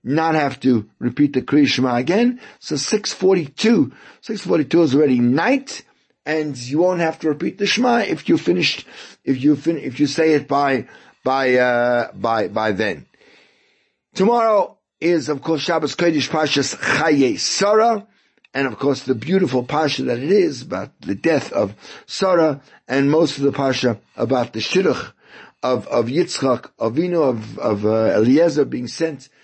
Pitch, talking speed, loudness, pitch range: 150 Hz, 165 wpm, -18 LUFS, 135-180 Hz